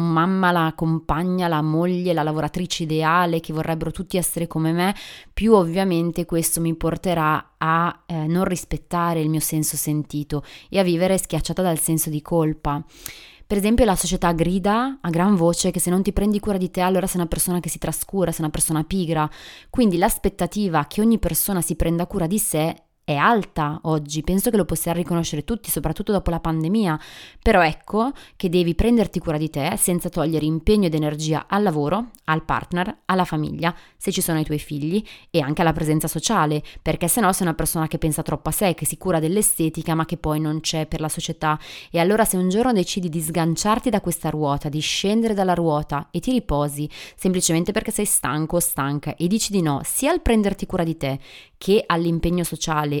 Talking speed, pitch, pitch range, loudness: 200 wpm, 170 Hz, 155-185 Hz, -21 LUFS